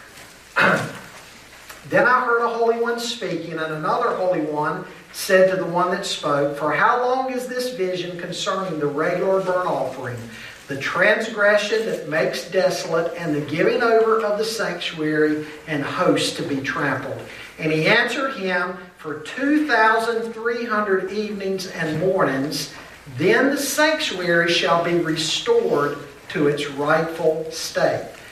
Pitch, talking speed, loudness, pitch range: 180 Hz, 135 wpm, -21 LUFS, 155-220 Hz